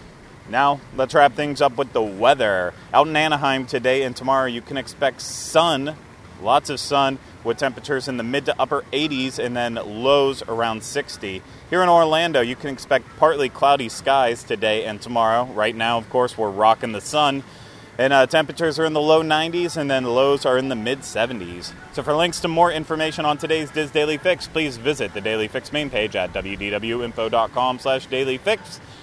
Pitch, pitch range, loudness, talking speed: 135 Hz, 120-150 Hz, -20 LUFS, 190 wpm